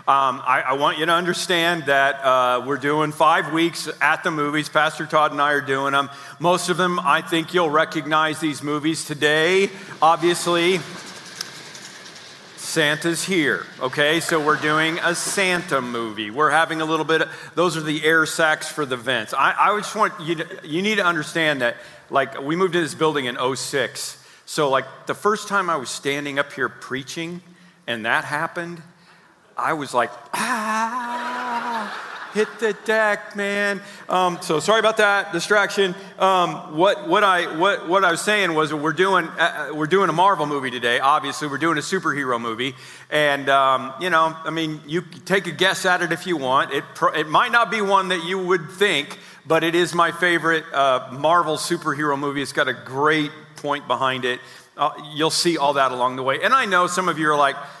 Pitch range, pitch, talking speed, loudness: 150-180 Hz, 160 Hz, 195 wpm, -20 LUFS